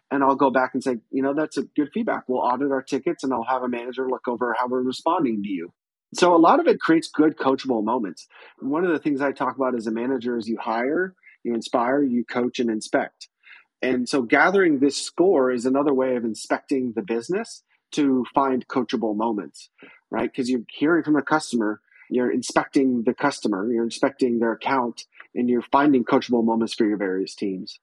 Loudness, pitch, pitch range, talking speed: -23 LUFS, 130 Hz, 120-140 Hz, 210 wpm